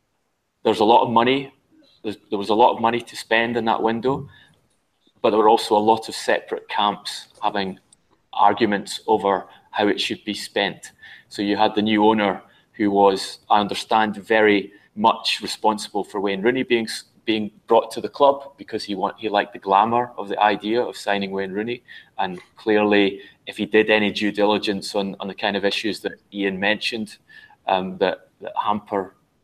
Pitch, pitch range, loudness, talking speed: 105 Hz, 100-115 Hz, -21 LUFS, 190 wpm